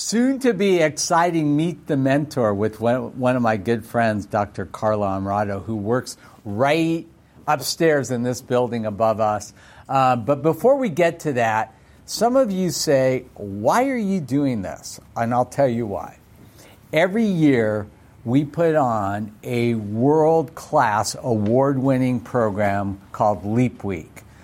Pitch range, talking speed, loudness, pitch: 110-155 Hz, 145 wpm, -21 LUFS, 125 Hz